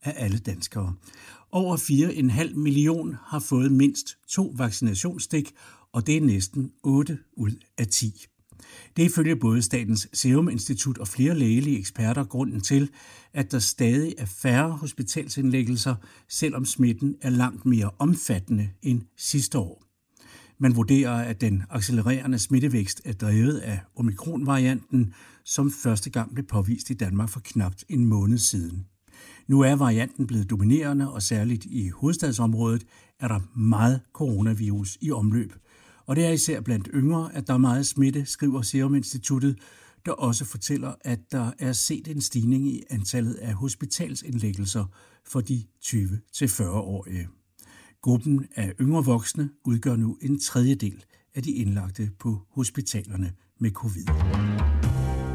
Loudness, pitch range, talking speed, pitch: -25 LUFS, 105-140 Hz, 140 wpm, 120 Hz